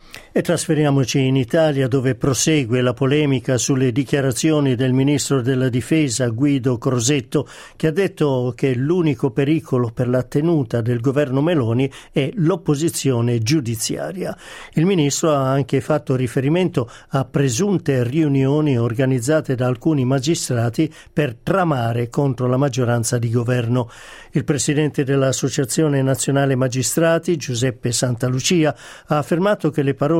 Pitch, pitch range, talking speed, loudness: 140 Hz, 130-155 Hz, 125 wpm, -19 LUFS